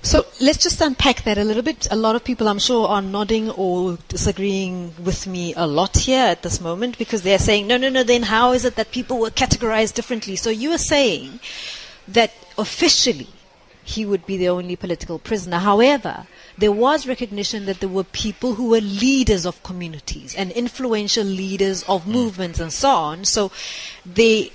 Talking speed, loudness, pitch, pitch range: 190 wpm, -19 LUFS, 215 Hz, 190-245 Hz